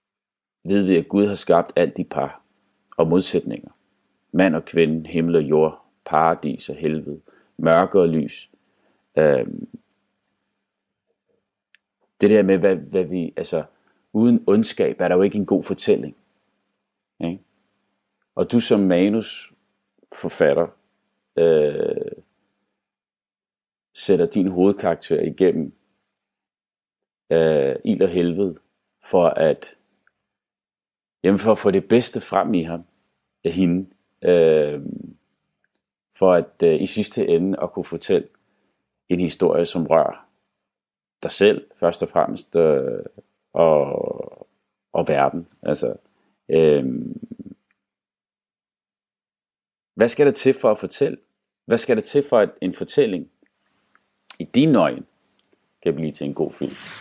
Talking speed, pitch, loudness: 125 wpm, 100 Hz, -20 LUFS